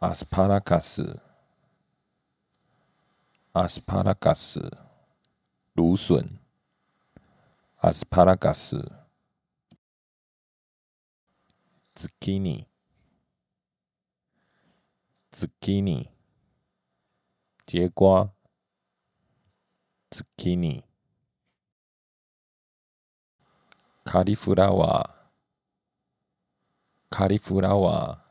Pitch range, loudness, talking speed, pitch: 85-95 Hz, -24 LUFS, 100 characters per minute, 95 Hz